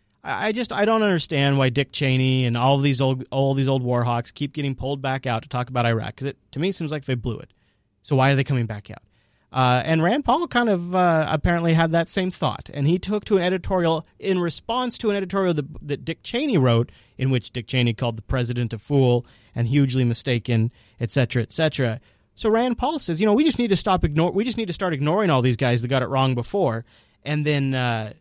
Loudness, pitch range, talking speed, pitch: -22 LUFS, 120-175 Hz, 240 wpm, 135 Hz